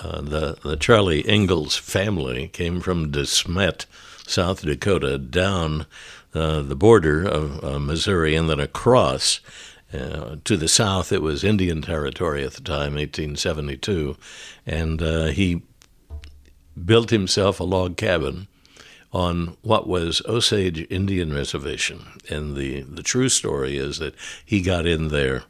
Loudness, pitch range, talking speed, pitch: -22 LUFS, 75-95 Hz, 135 wpm, 80 Hz